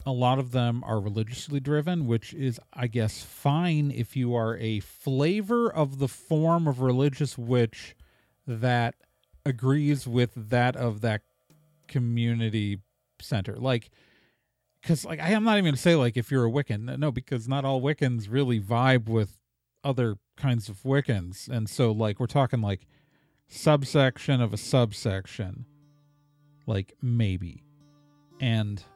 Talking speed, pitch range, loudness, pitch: 145 wpm, 115-145 Hz, -27 LUFS, 125 Hz